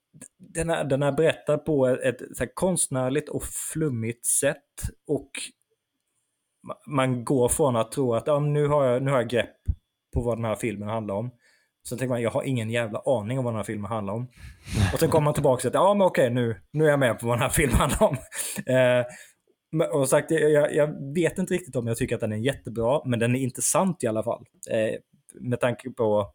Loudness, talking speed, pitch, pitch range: -25 LUFS, 225 wpm, 130 Hz, 115-150 Hz